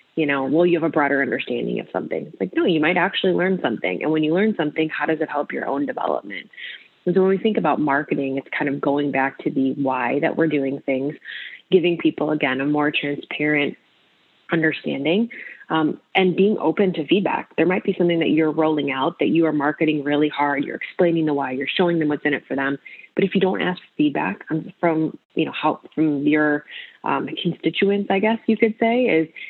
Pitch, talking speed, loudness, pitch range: 160 Hz, 220 wpm, -21 LUFS, 145-180 Hz